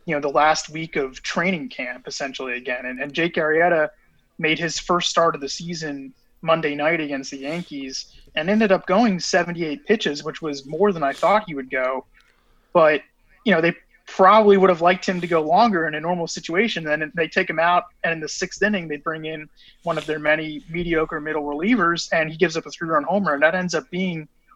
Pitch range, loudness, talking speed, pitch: 150-180 Hz, -21 LUFS, 220 wpm, 165 Hz